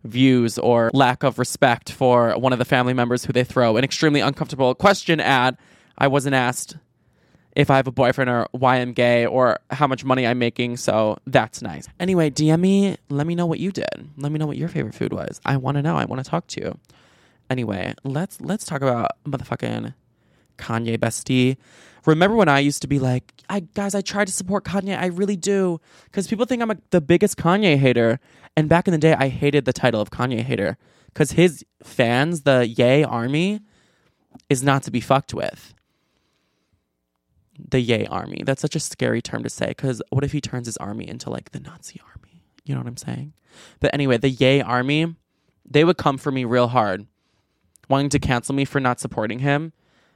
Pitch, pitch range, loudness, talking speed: 135 Hz, 125-155 Hz, -20 LUFS, 205 wpm